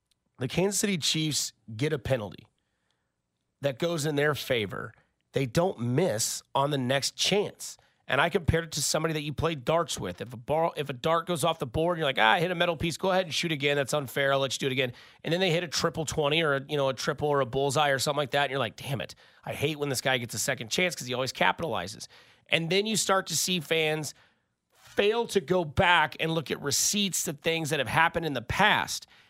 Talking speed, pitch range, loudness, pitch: 245 wpm, 135-170 Hz, -27 LUFS, 150 Hz